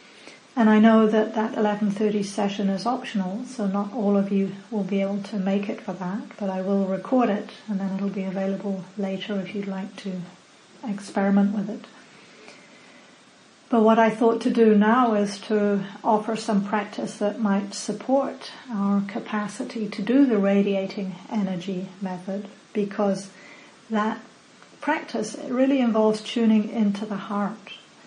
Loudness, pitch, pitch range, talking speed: -24 LUFS, 210 Hz, 200-225 Hz, 155 wpm